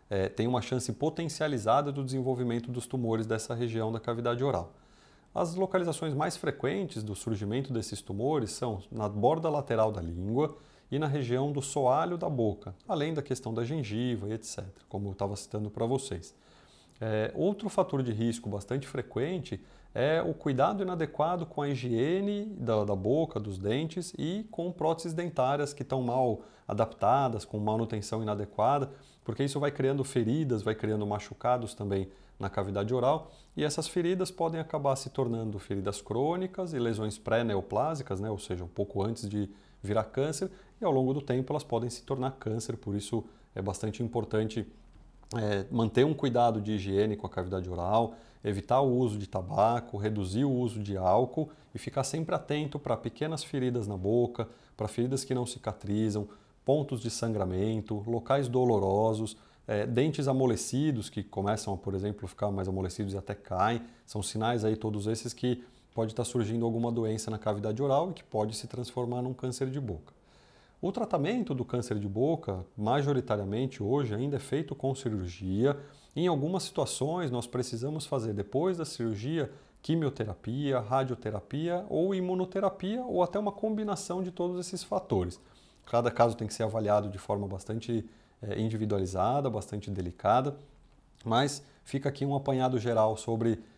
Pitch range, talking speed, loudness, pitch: 105-140 Hz, 165 wpm, -32 LUFS, 120 Hz